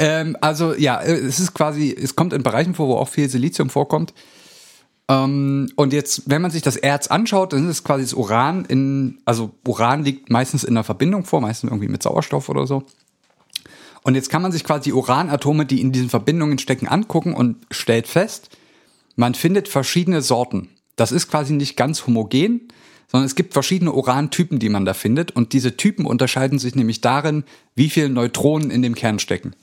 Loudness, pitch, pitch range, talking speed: -19 LUFS, 140 Hz, 125-155 Hz, 190 wpm